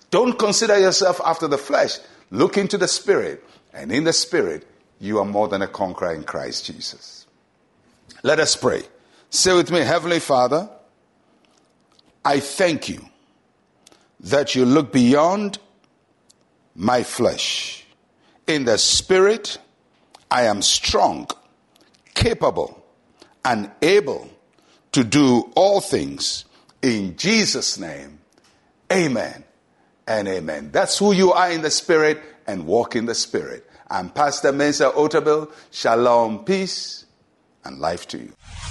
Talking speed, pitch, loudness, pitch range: 125 wpm, 165 Hz, -19 LUFS, 135-200 Hz